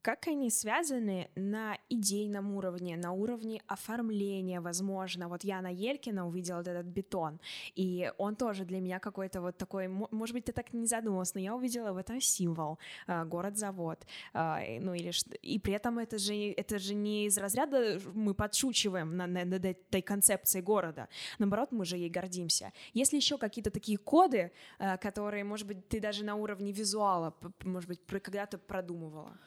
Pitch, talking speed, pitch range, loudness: 200 Hz, 170 wpm, 180-215 Hz, -34 LUFS